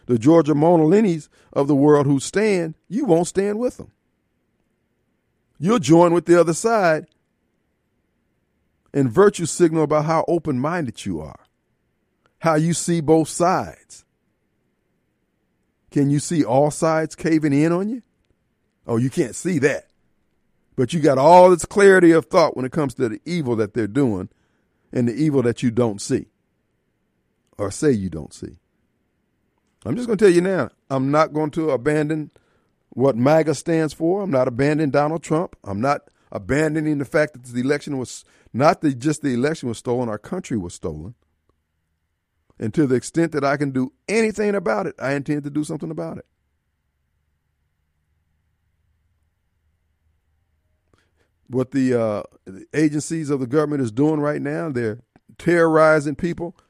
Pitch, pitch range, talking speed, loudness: 145 Hz, 115-165 Hz, 160 wpm, -19 LUFS